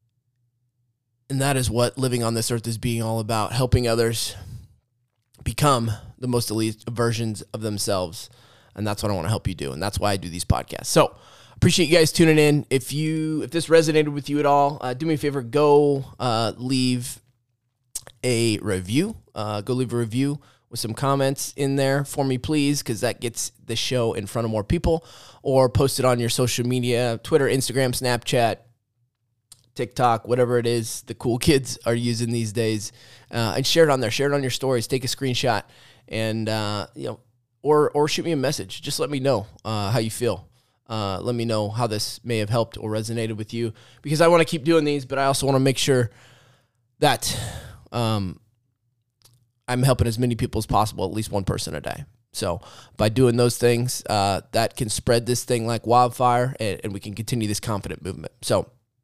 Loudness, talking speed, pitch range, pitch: -23 LUFS, 200 wpm, 110-130 Hz, 120 Hz